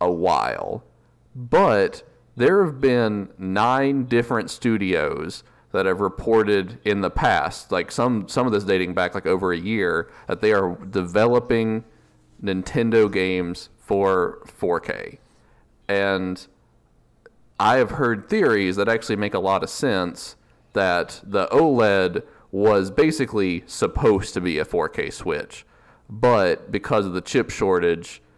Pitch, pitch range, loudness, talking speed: 105 Hz, 95-120 Hz, -21 LUFS, 135 wpm